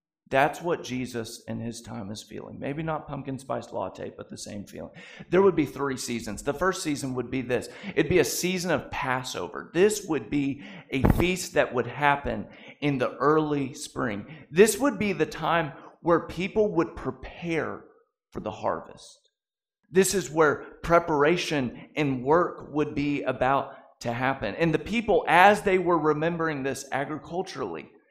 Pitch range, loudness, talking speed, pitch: 130-180 Hz, -26 LUFS, 165 wpm, 150 Hz